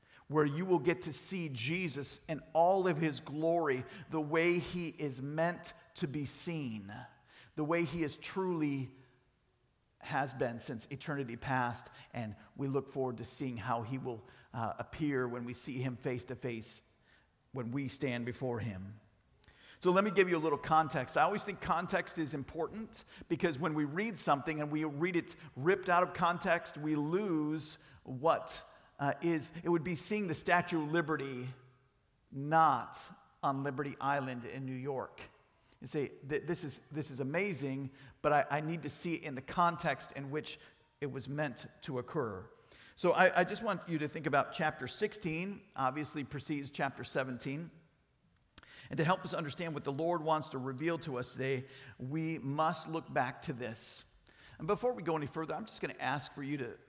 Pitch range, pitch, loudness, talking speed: 130-170 Hz, 150 Hz, -36 LUFS, 180 wpm